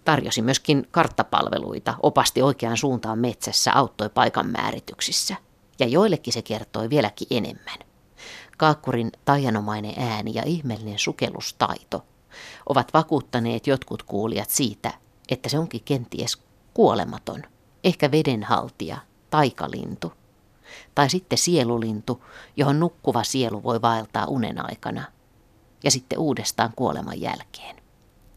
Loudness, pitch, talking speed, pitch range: -23 LUFS, 125 Hz, 105 wpm, 110-145 Hz